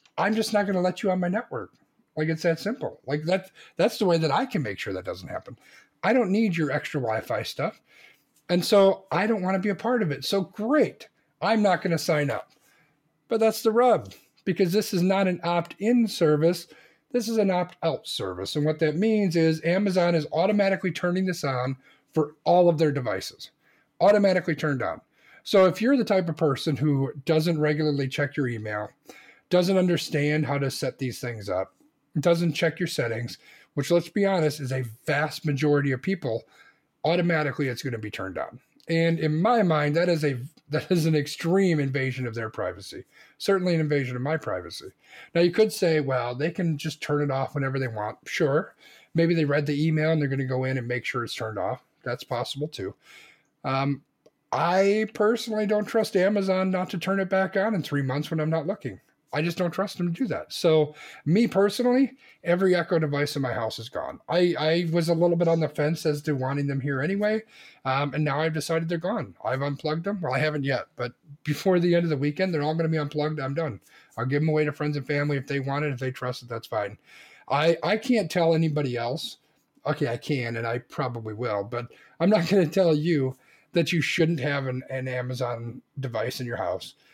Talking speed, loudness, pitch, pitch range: 220 wpm, -25 LUFS, 155 Hz, 140-185 Hz